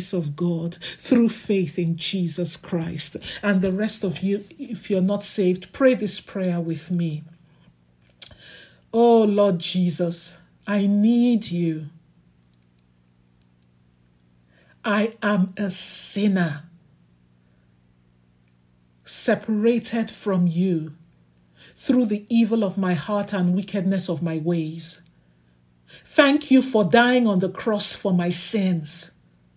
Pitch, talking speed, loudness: 175 Hz, 110 wpm, -21 LUFS